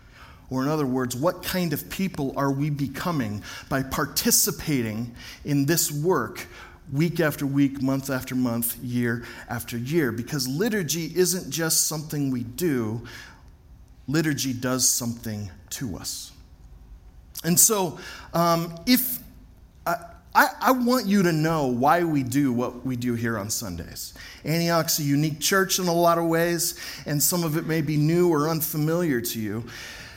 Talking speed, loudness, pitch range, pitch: 155 wpm, -24 LUFS, 120-170 Hz, 145 Hz